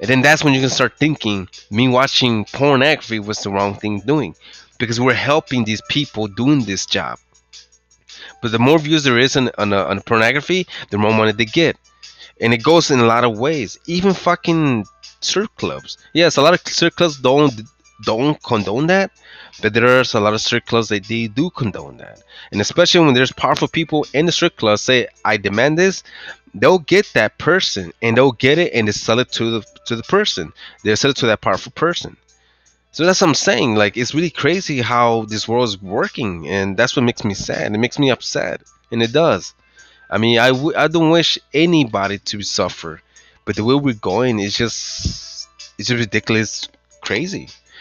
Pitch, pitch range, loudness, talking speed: 120 Hz, 110-150 Hz, -16 LUFS, 200 wpm